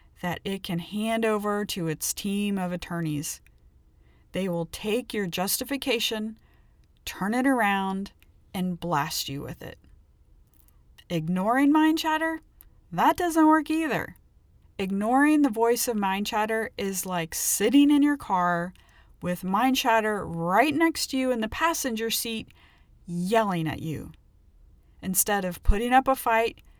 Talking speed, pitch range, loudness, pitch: 140 wpm, 175-245 Hz, -25 LUFS, 205 Hz